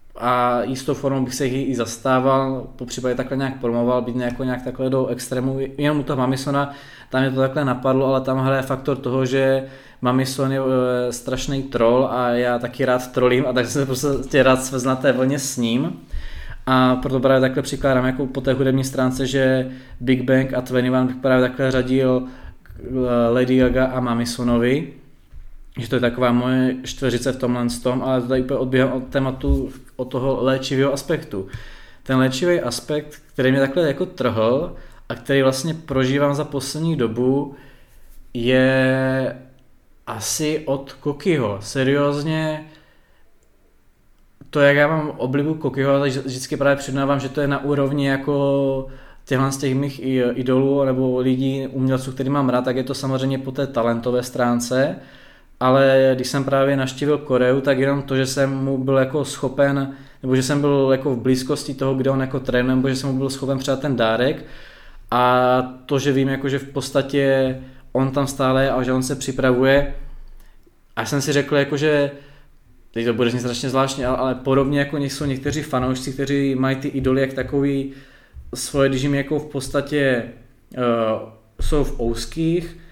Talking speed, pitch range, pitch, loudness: 170 wpm, 125-140 Hz, 130 Hz, -20 LUFS